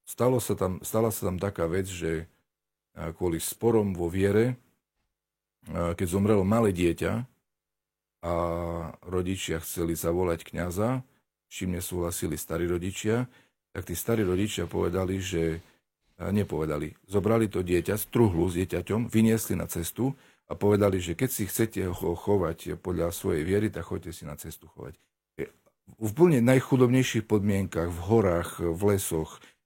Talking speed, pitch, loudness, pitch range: 135 wpm, 95 Hz, -28 LUFS, 85-110 Hz